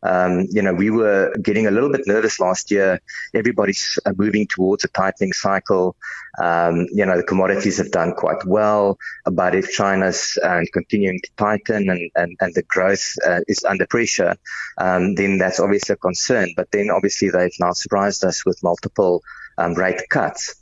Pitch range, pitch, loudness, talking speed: 90-100 Hz, 95 Hz, -19 LUFS, 180 wpm